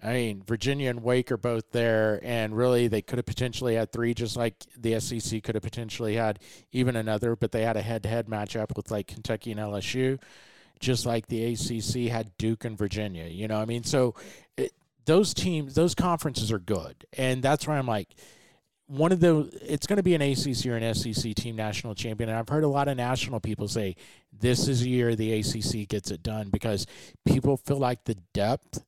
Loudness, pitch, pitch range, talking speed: -28 LUFS, 115 Hz, 110-125 Hz, 210 wpm